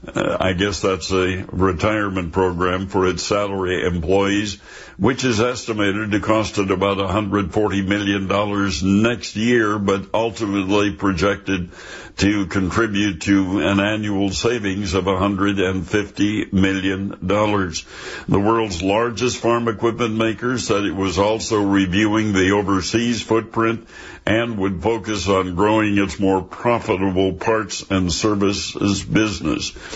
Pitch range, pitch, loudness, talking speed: 95-110 Hz, 100 Hz, -19 LUFS, 120 wpm